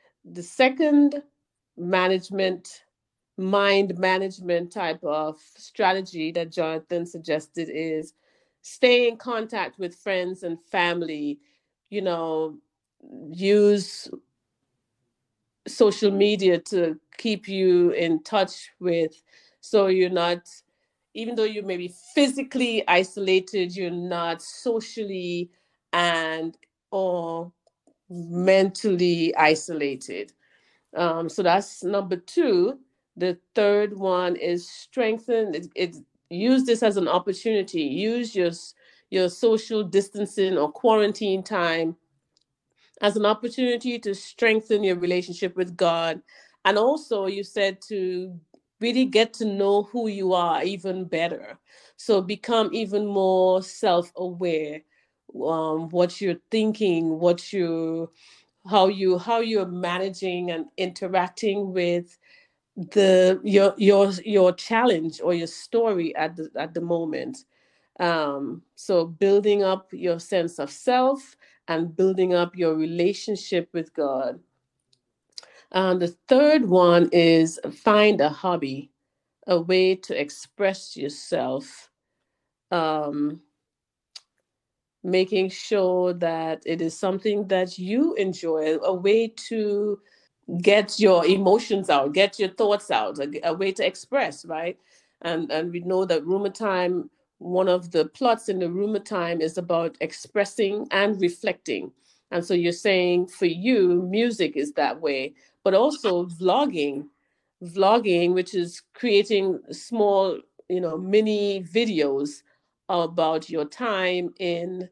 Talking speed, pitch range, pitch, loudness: 120 wpm, 170-205 Hz, 185 Hz, -23 LUFS